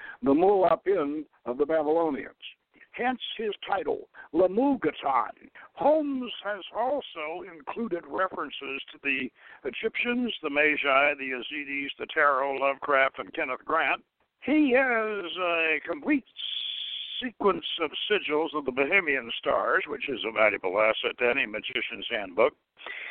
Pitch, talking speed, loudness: 165 Hz, 120 wpm, -27 LUFS